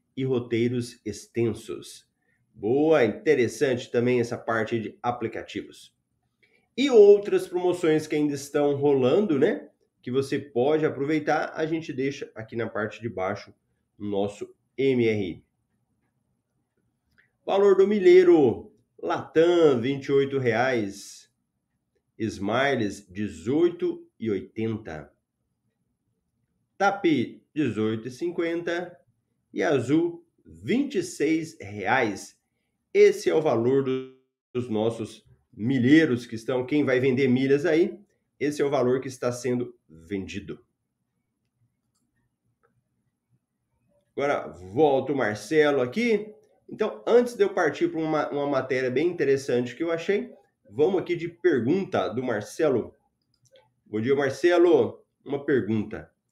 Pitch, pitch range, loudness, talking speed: 130 Hz, 115-175 Hz, -24 LUFS, 110 wpm